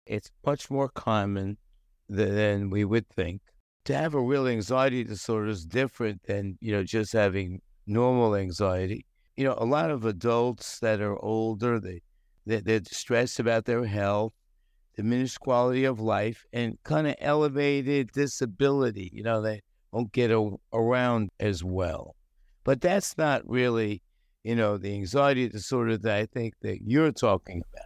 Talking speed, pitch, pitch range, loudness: 160 wpm, 110 Hz, 100-125 Hz, -28 LUFS